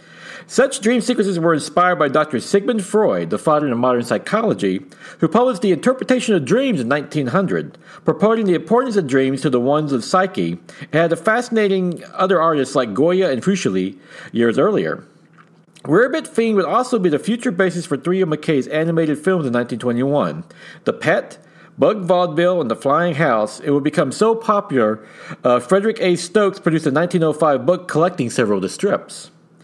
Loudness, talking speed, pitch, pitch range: -18 LUFS, 170 wpm, 175 Hz, 140-200 Hz